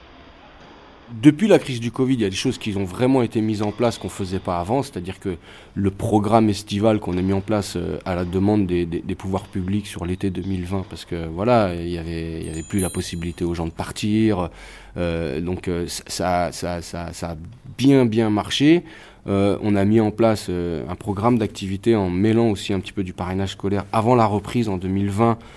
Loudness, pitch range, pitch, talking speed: -21 LUFS, 90-110 Hz, 100 Hz, 215 wpm